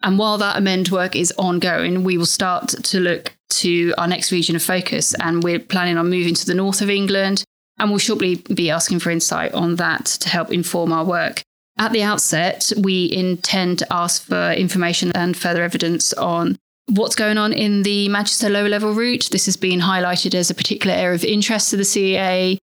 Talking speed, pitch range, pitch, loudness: 205 wpm, 175-205 Hz, 185 Hz, -18 LUFS